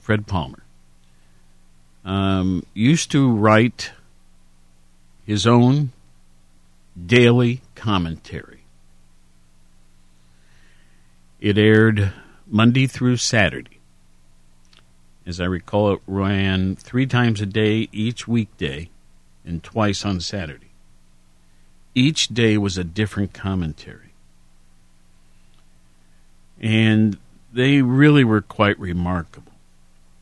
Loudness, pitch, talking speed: -19 LUFS, 85 Hz, 85 wpm